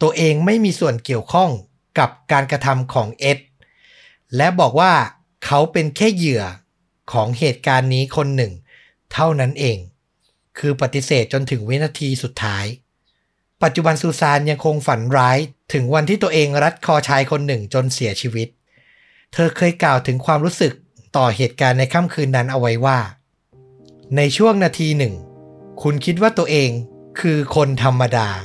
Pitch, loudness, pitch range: 140 Hz, -17 LUFS, 125-160 Hz